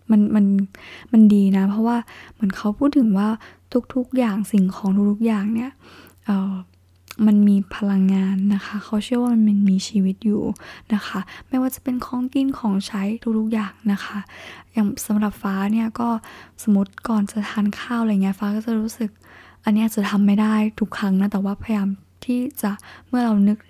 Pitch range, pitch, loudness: 200-225 Hz, 210 Hz, -21 LUFS